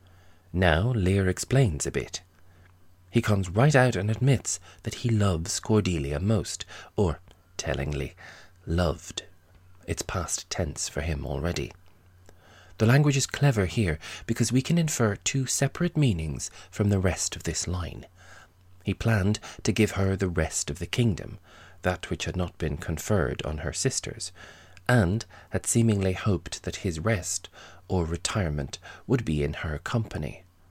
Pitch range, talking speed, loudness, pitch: 85-110 Hz, 150 wpm, -27 LUFS, 95 Hz